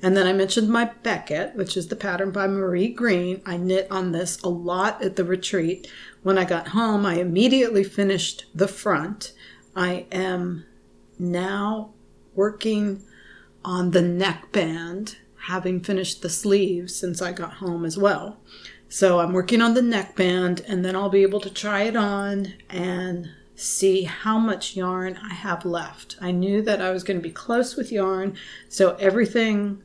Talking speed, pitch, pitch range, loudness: 170 wpm, 190 Hz, 180-205 Hz, -23 LUFS